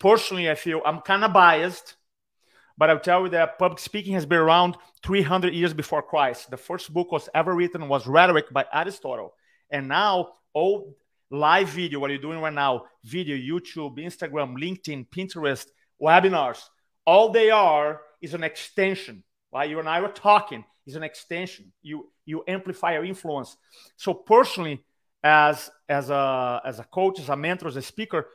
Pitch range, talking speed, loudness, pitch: 150-185 Hz, 165 wpm, -23 LUFS, 165 Hz